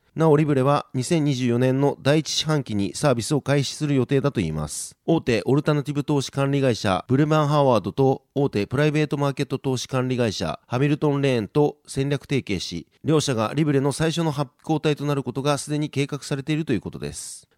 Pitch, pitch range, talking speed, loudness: 140 Hz, 125-150 Hz, 420 characters per minute, -23 LUFS